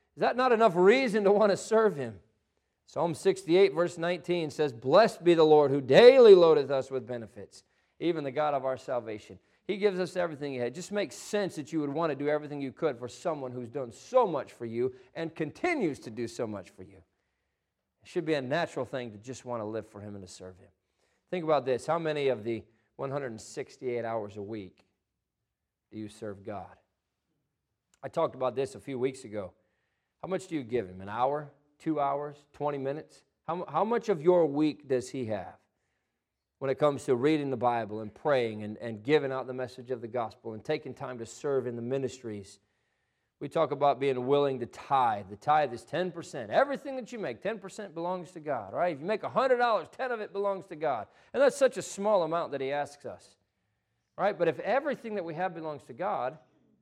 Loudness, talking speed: -29 LUFS, 215 wpm